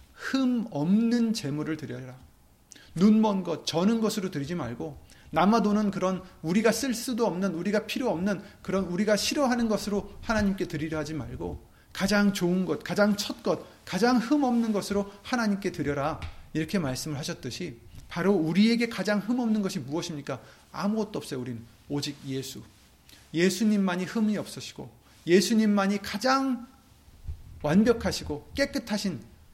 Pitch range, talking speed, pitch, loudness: 150-215 Hz, 325 characters per minute, 190 Hz, -27 LUFS